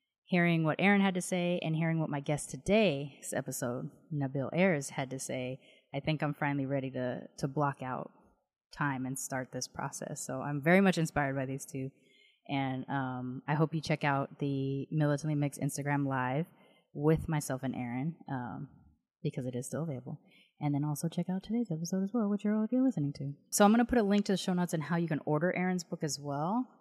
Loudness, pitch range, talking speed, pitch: -33 LUFS, 135-175 Hz, 215 wpm, 150 Hz